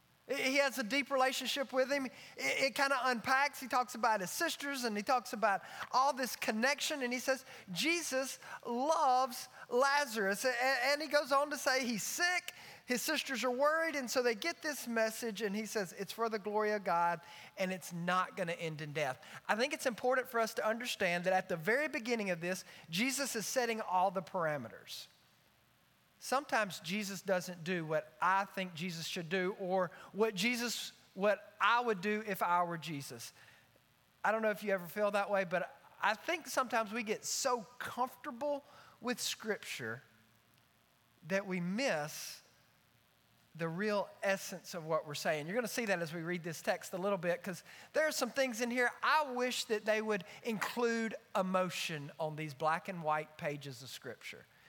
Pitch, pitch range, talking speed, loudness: 215 Hz, 180-260 Hz, 190 wpm, -35 LUFS